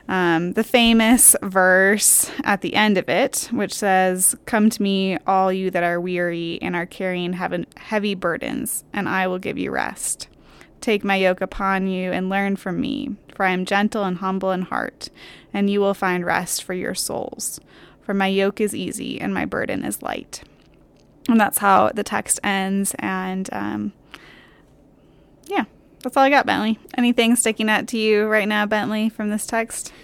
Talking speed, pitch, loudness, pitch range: 180 wpm, 200 Hz, -20 LUFS, 185-220 Hz